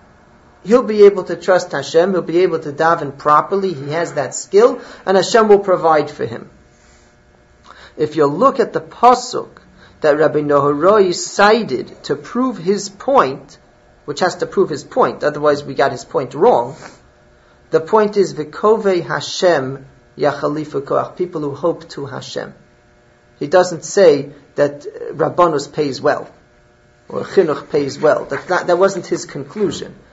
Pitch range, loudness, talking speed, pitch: 150-200 Hz, -16 LUFS, 155 wpm, 175 Hz